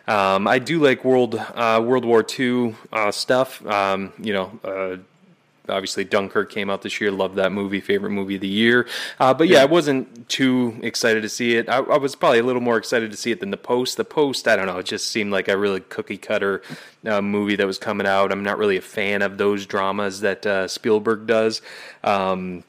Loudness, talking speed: -20 LUFS, 225 wpm